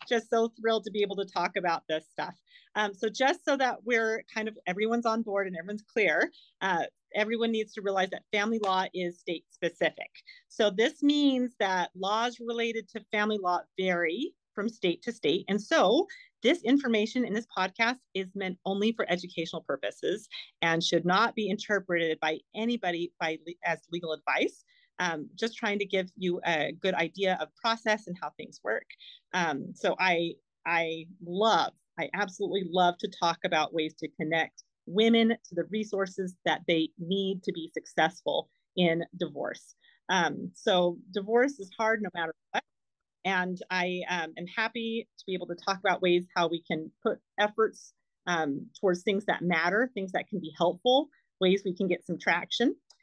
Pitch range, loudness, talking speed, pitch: 175-225 Hz, -30 LUFS, 180 wpm, 195 Hz